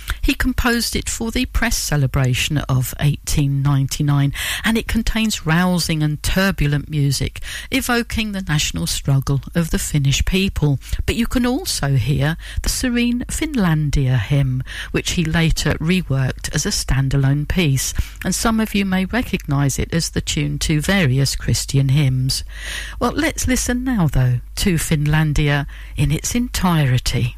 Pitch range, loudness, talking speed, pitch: 135-195 Hz, -19 LUFS, 140 wpm, 150 Hz